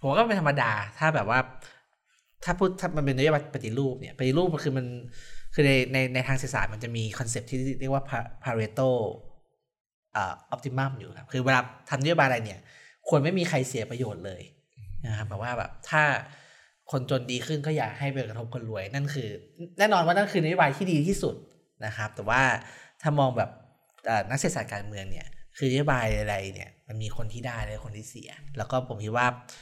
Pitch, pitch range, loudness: 130 Hz, 115-145 Hz, -28 LUFS